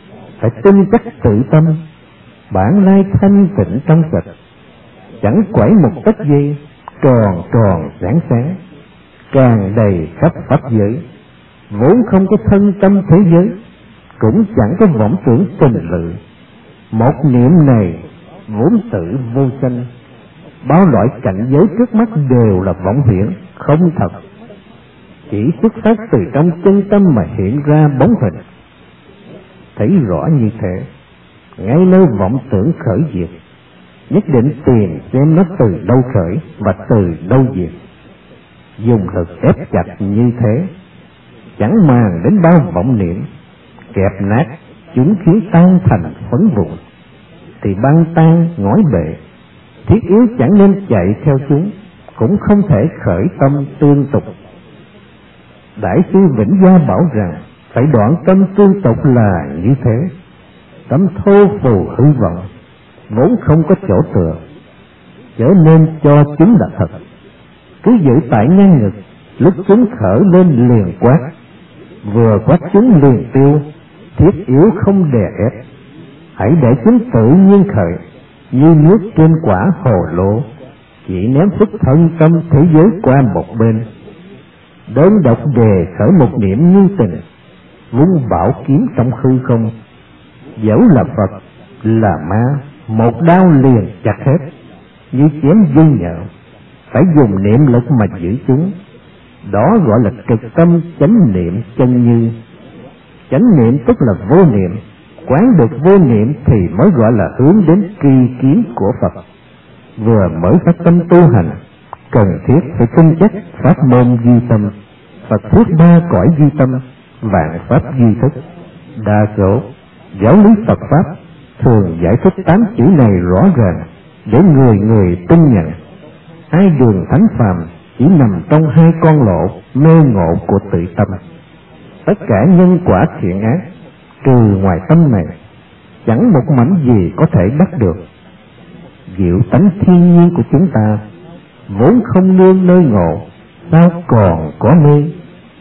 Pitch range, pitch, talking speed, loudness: 105-170 Hz, 135 Hz, 150 wpm, -10 LUFS